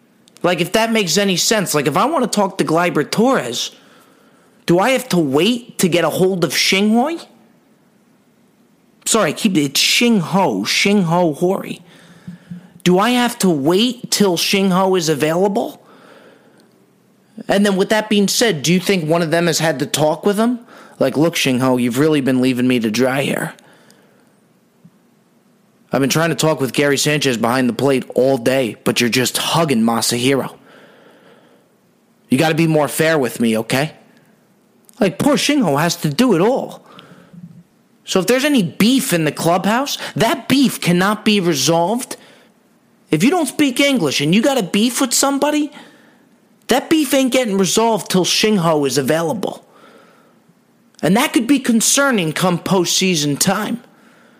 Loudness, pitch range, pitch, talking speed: -16 LUFS, 165-235 Hz, 200 Hz, 160 wpm